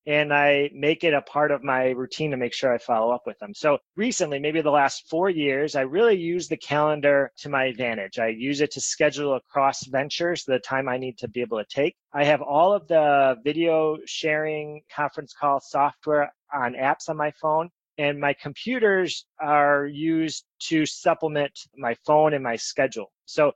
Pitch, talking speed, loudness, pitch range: 145 Hz, 195 wpm, -24 LUFS, 135-155 Hz